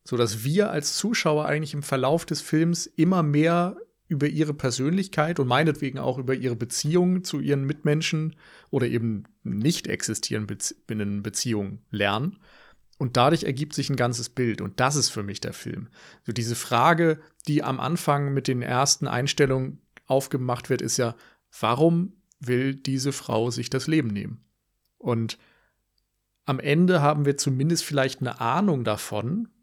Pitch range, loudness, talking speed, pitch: 120-155 Hz, -25 LUFS, 155 wpm, 140 Hz